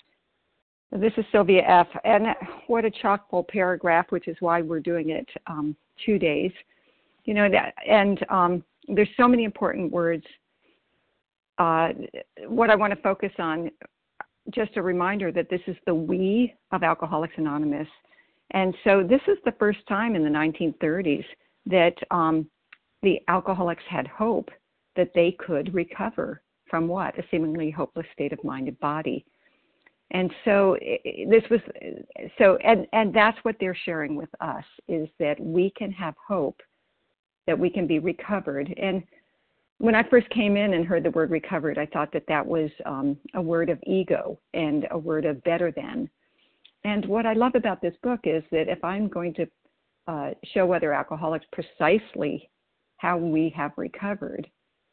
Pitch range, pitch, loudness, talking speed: 165-215 Hz, 180 Hz, -25 LUFS, 165 wpm